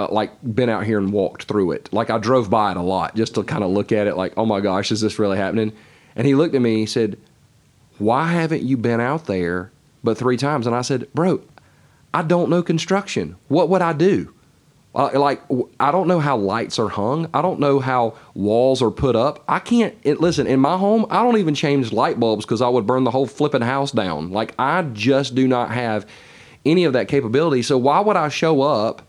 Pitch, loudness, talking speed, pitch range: 125 Hz, -19 LUFS, 235 wpm, 110-150 Hz